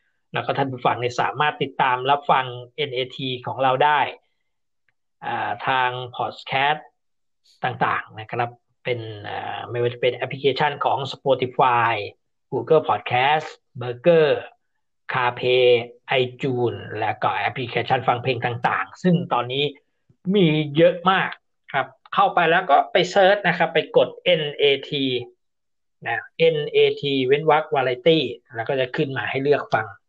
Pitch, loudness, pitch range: 135 Hz, -21 LUFS, 125-155 Hz